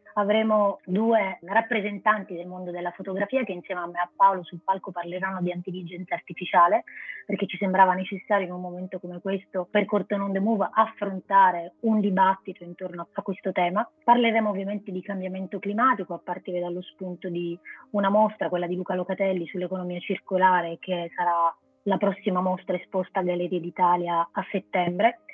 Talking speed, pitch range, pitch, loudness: 165 wpm, 180-200 Hz, 190 Hz, -26 LUFS